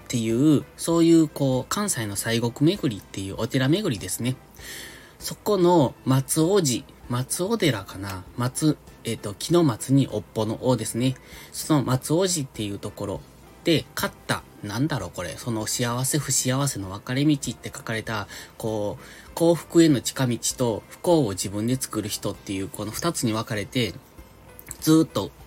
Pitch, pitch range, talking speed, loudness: 125 Hz, 110-150 Hz, 305 characters per minute, -24 LUFS